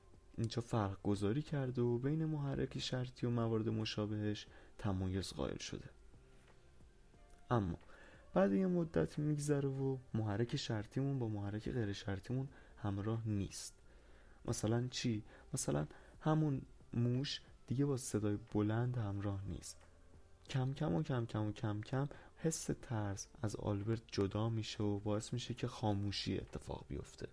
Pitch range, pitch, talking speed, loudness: 100-125 Hz, 110 Hz, 130 wpm, -40 LUFS